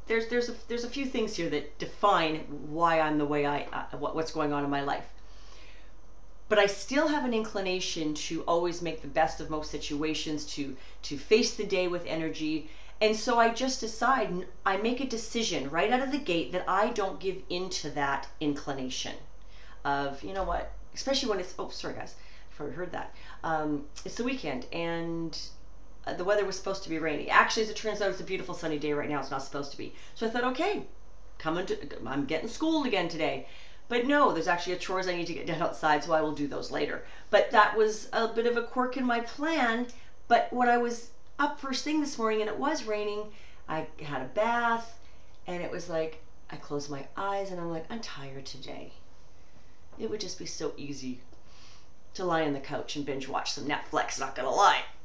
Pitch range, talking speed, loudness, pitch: 150-225 Hz, 215 wpm, -30 LUFS, 180 Hz